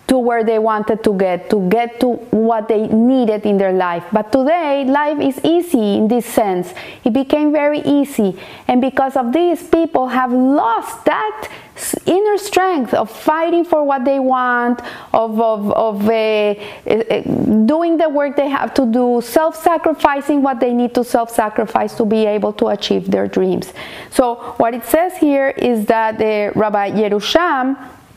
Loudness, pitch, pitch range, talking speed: -15 LUFS, 250 Hz, 220-285 Hz, 170 wpm